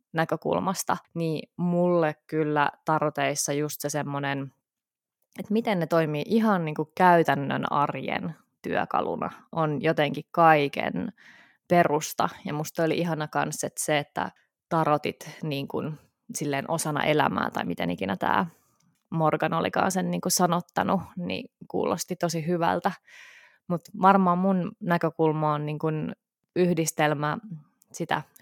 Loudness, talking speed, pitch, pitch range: -26 LUFS, 120 wpm, 160 Hz, 150-175 Hz